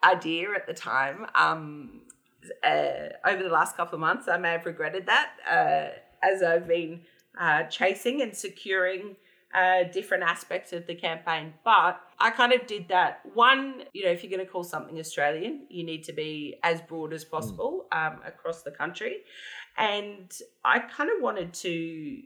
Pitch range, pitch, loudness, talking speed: 165-245 Hz, 185 Hz, -27 LUFS, 175 wpm